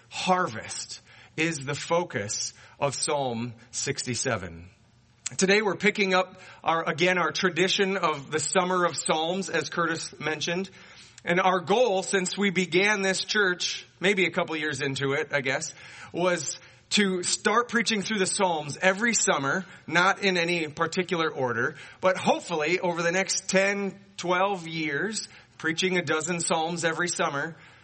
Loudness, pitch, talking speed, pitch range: -26 LUFS, 175 Hz, 145 wpm, 150-190 Hz